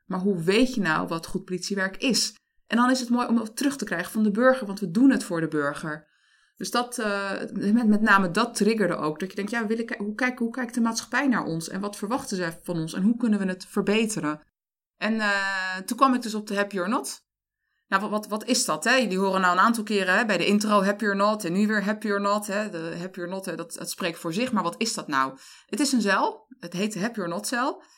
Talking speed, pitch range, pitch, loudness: 270 wpm, 185-230 Hz, 205 Hz, -25 LUFS